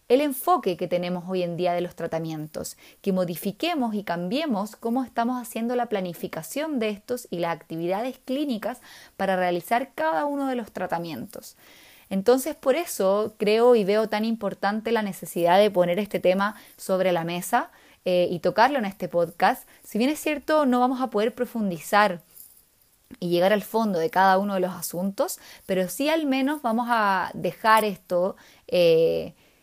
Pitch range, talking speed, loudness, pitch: 180-245 Hz, 170 wpm, -25 LUFS, 205 Hz